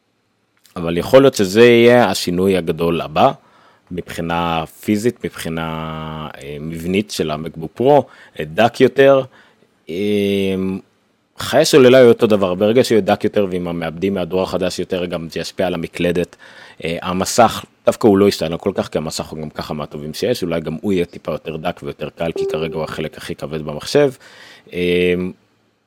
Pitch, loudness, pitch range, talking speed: 90 Hz, -16 LUFS, 80-100 Hz, 150 wpm